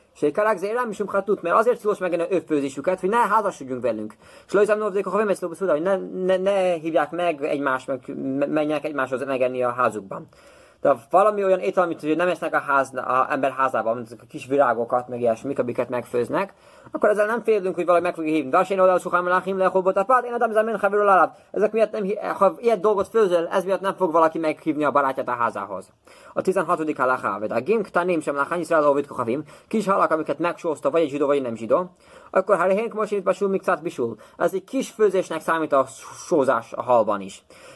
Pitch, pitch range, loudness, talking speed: 175 Hz, 145-200 Hz, -22 LUFS, 195 wpm